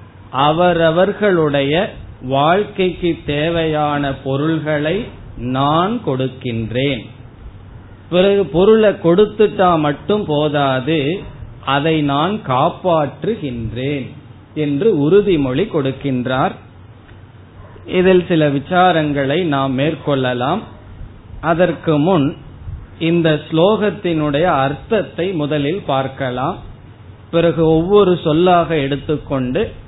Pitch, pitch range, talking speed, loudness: 145 Hz, 130-170 Hz, 65 wpm, -16 LUFS